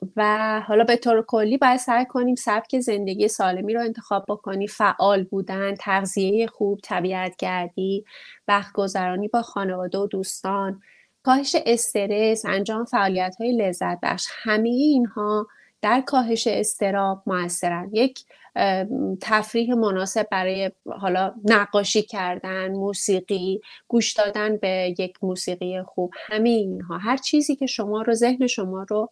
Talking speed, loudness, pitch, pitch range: 130 wpm, -23 LUFS, 205 Hz, 190-230 Hz